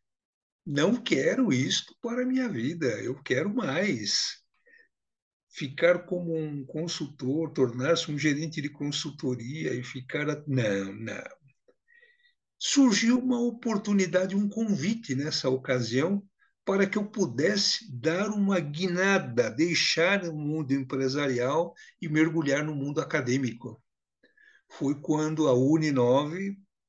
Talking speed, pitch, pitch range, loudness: 110 wpm, 160 Hz, 135-200 Hz, -27 LUFS